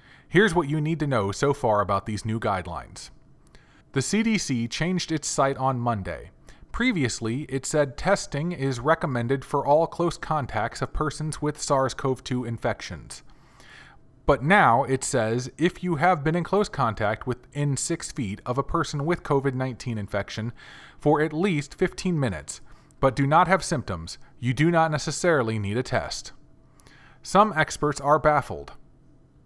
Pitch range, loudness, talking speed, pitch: 125-160 Hz, -25 LUFS, 155 wpm, 140 Hz